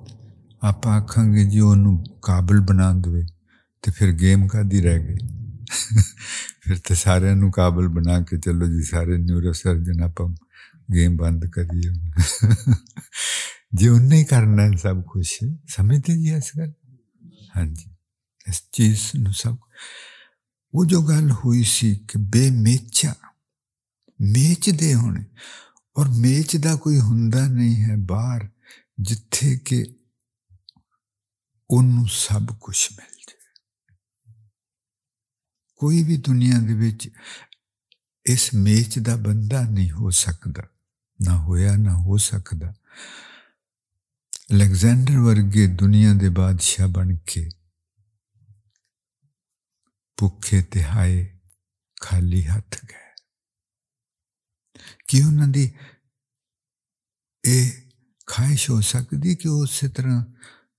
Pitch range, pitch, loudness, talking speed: 95-125 Hz, 105 Hz, -19 LUFS, 100 wpm